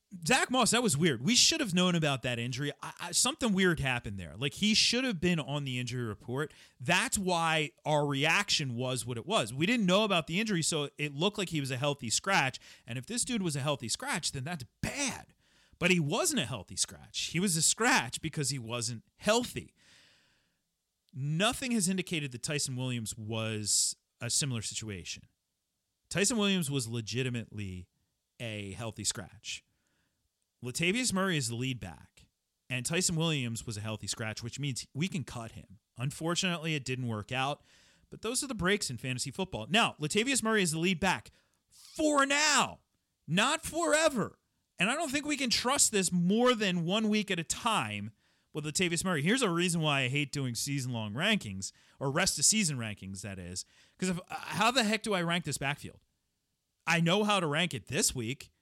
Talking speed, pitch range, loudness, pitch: 190 wpm, 120-190 Hz, -30 LUFS, 150 Hz